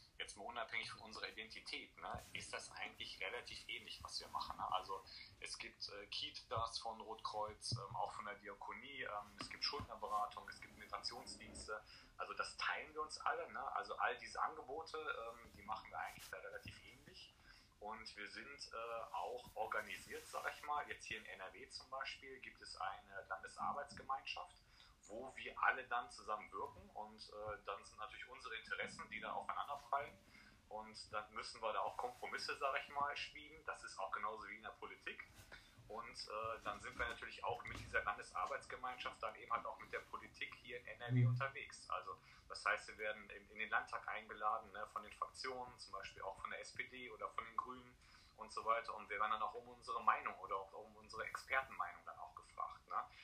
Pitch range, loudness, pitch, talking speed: 105-155 Hz, -47 LUFS, 130 Hz, 185 wpm